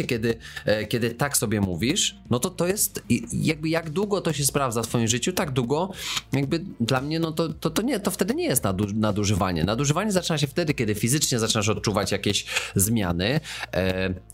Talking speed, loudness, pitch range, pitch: 190 wpm, -24 LUFS, 105-155 Hz, 120 Hz